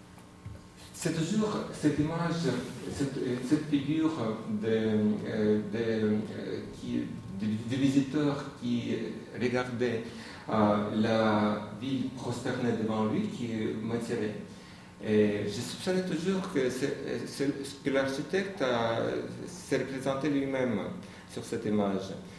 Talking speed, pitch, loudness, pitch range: 110 wpm, 125 Hz, -31 LUFS, 110-140 Hz